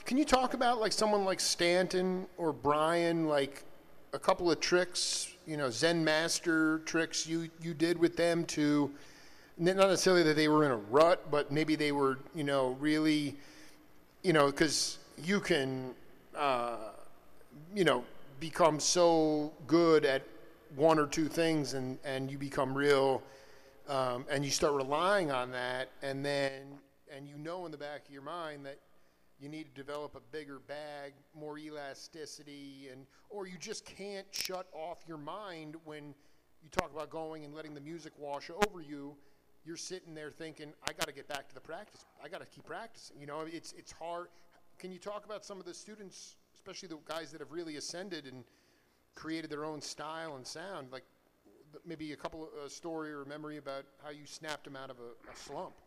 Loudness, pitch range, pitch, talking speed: -33 LUFS, 140-170 Hz, 155 Hz, 185 wpm